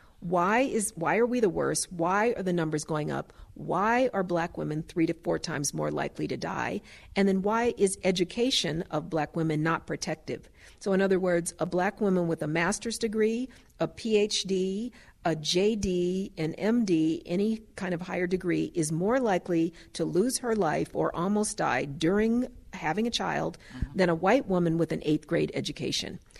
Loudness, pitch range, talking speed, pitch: -28 LUFS, 165-215 Hz, 180 wpm, 185 Hz